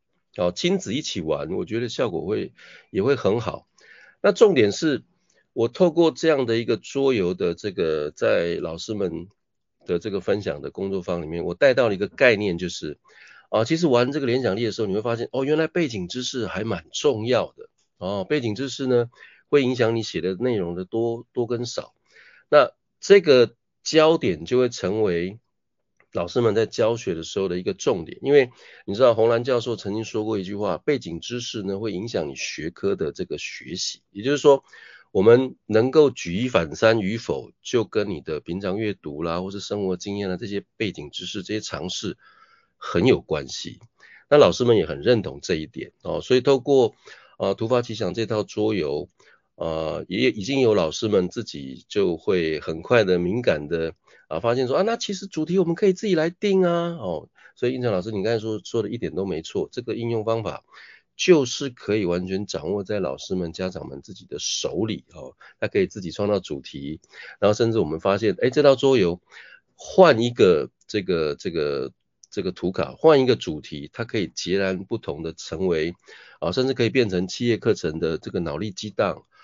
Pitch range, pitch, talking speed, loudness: 95-140 Hz, 115 Hz, 285 characters per minute, -23 LUFS